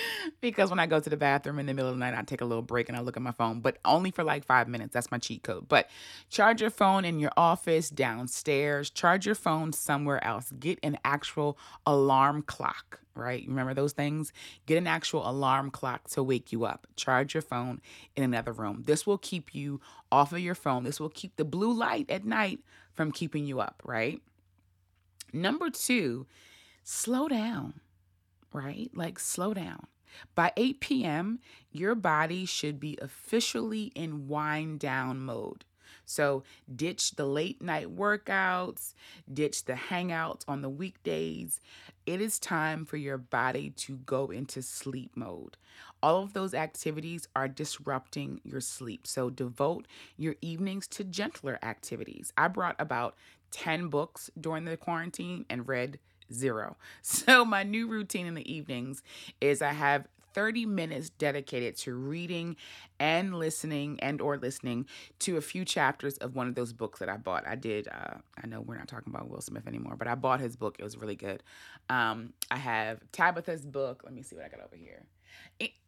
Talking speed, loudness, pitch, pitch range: 180 wpm, -31 LUFS, 145 Hz, 125-170 Hz